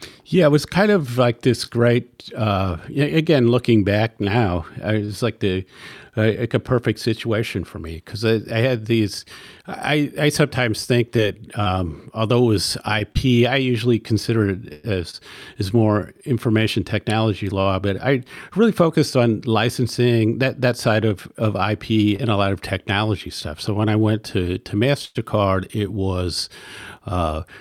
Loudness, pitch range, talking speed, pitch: -20 LUFS, 100-125 Hz, 165 wpm, 110 Hz